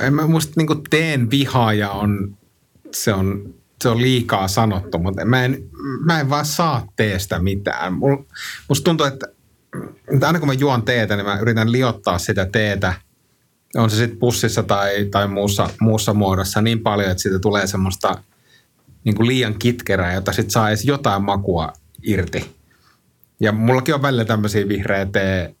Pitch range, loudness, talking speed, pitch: 100-130 Hz, -18 LUFS, 160 wpm, 110 Hz